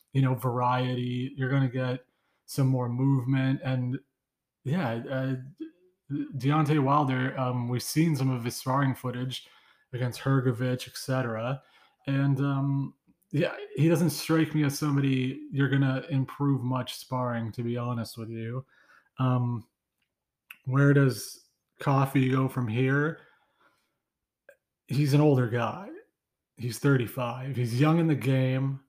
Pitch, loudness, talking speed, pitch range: 130 Hz, -28 LUFS, 130 wpm, 125-140 Hz